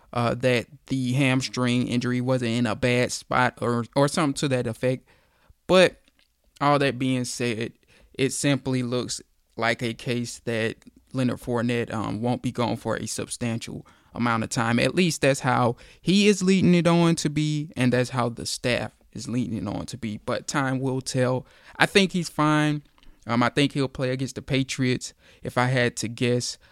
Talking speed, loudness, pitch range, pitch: 185 wpm, -24 LUFS, 120-135 Hz, 125 Hz